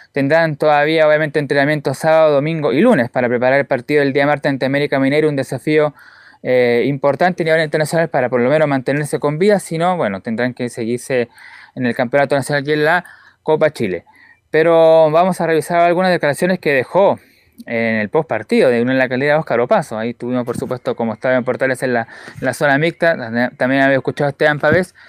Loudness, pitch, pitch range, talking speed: -15 LUFS, 145 Hz, 125-160 Hz, 210 wpm